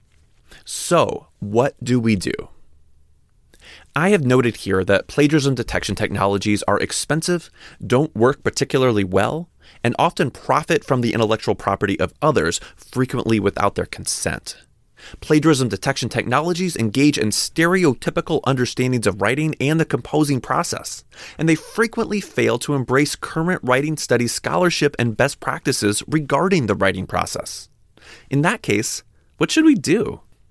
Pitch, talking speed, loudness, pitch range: 130 Hz, 135 wpm, -19 LUFS, 105-155 Hz